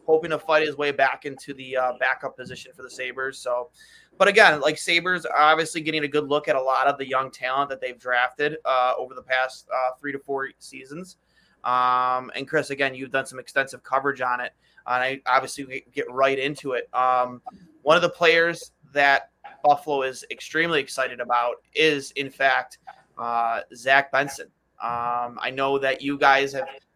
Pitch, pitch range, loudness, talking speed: 135 Hz, 130-150 Hz, -23 LUFS, 190 wpm